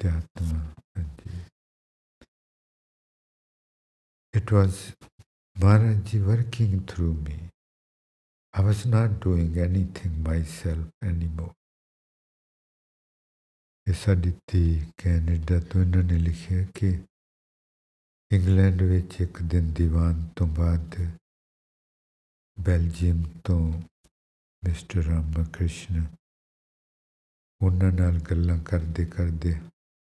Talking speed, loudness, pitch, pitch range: 50 wpm, -26 LUFS, 85 Hz, 80-95 Hz